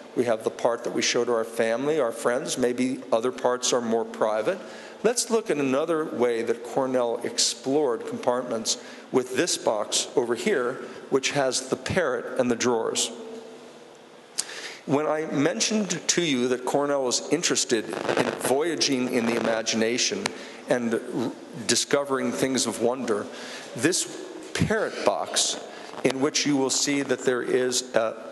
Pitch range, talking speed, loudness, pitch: 120-145 Hz, 155 wpm, -25 LUFS, 130 Hz